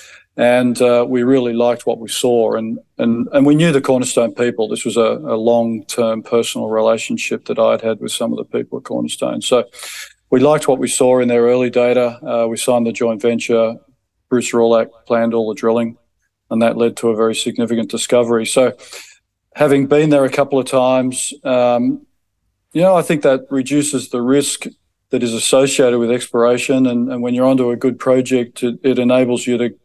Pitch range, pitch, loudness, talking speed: 115-130 Hz, 120 Hz, -15 LUFS, 200 wpm